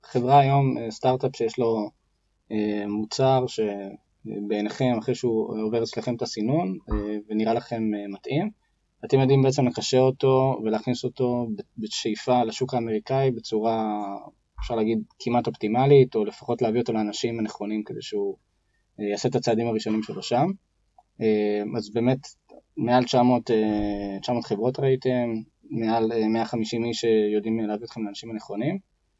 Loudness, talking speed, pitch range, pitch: -25 LUFS, 135 wpm, 105-125 Hz, 115 Hz